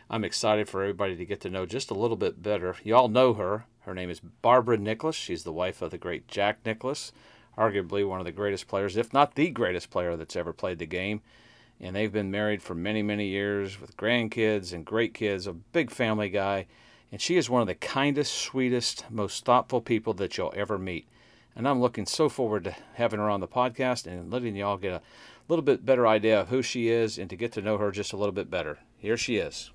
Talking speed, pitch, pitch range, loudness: 230 wpm, 105 Hz, 100-120 Hz, -28 LUFS